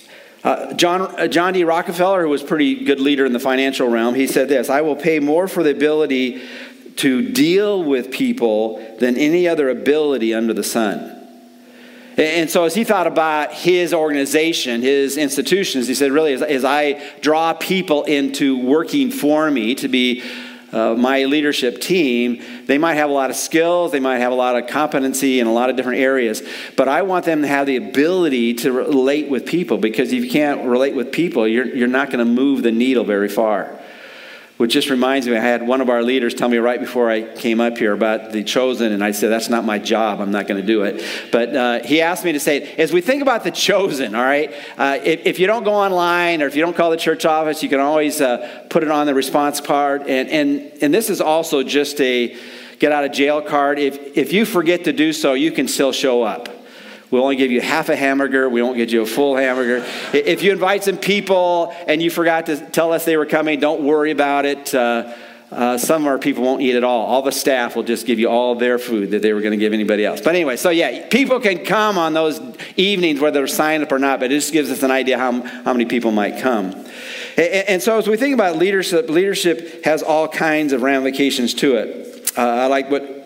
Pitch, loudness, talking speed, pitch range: 140 Hz, -17 LUFS, 235 wpm, 125-165 Hz